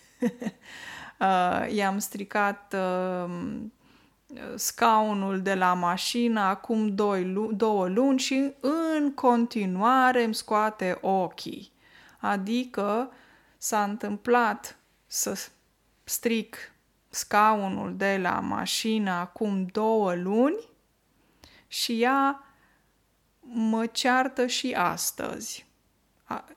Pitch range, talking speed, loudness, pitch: 195-245 Hz, 85 wpm, -26 LUFS, 220 Hz